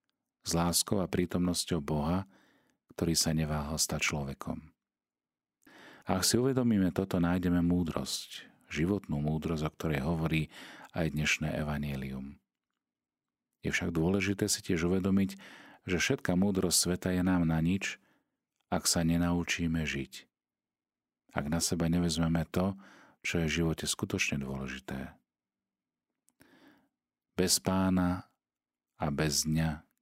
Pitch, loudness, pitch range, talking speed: 85 Hz, -31 LUFS, 75-90 Hz, 115 wpm